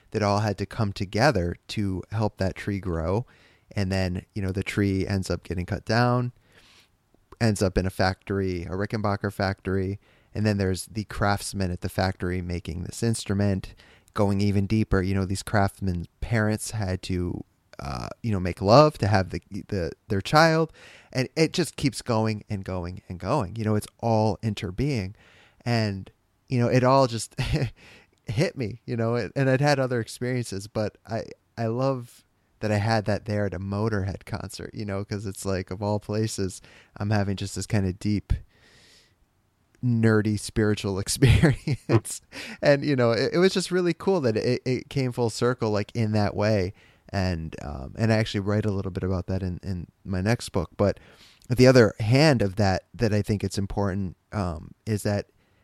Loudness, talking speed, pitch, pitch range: -26 LUFS, 185 wpm, 105 Hz, 95-115 Hz